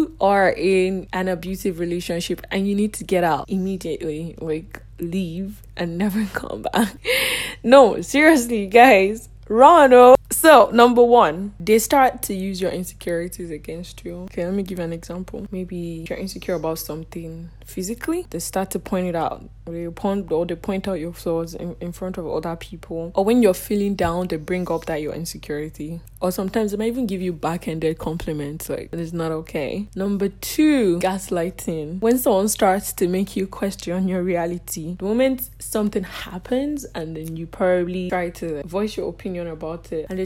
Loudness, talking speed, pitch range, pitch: -20 LUFS, 180 wpm, 170-205 Hz, 185 Hz